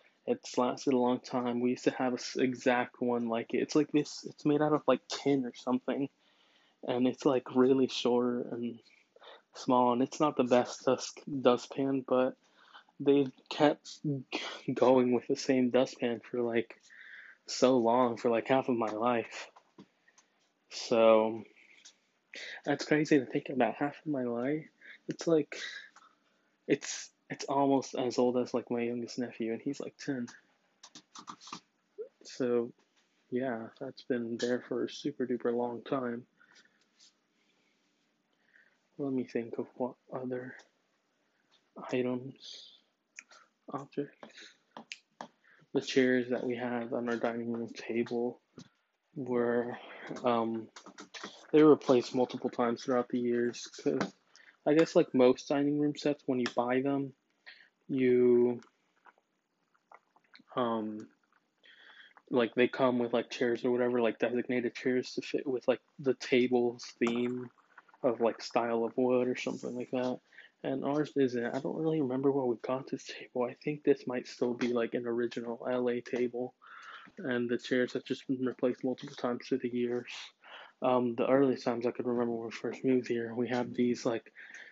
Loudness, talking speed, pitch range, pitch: -32 LUFS, 150 wpm, 120-135 Hz, 125 Hz